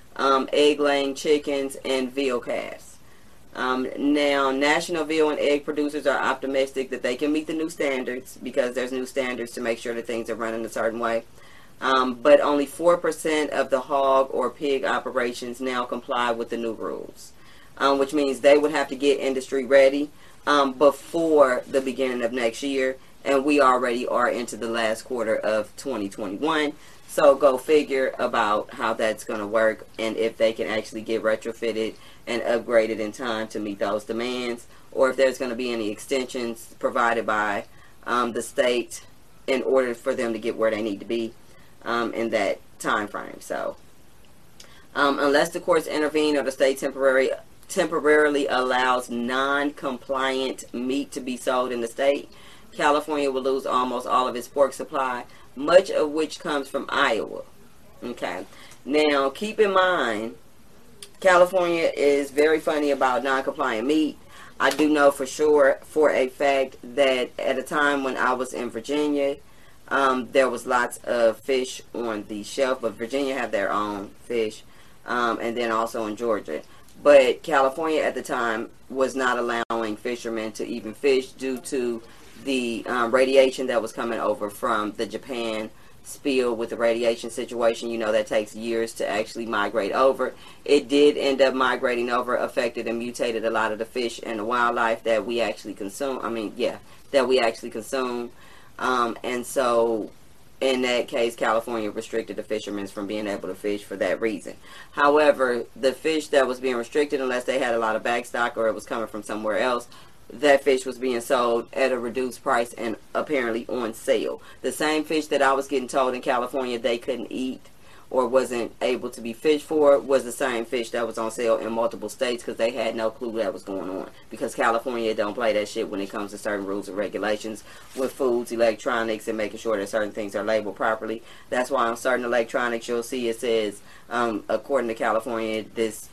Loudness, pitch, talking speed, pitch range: -24 LUFS, 125 Hz, 185 wpm, 115-140 Hz